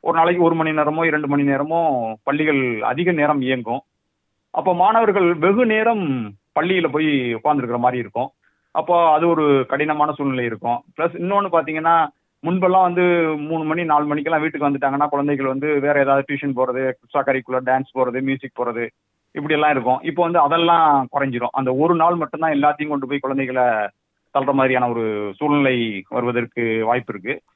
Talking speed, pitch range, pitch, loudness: 150 wpm, 130-165 Hz, 145 Hz, -19 LUFS